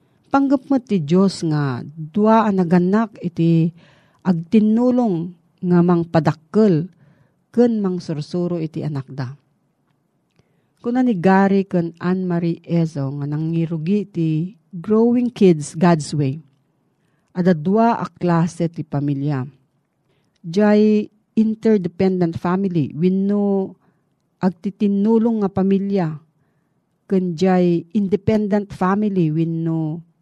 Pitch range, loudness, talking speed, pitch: 160-200 Hz, -19 LUFS, 100 wpm, 175 Hz